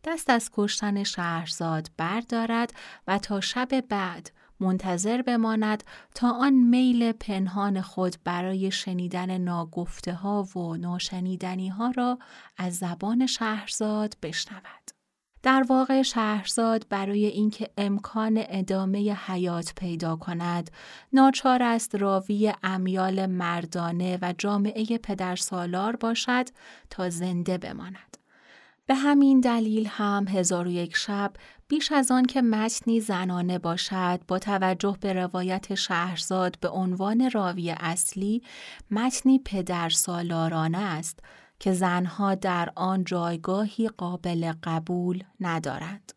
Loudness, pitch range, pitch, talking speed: -26 LUFS, 180-225 Hz, 195 Hz, 110 wpm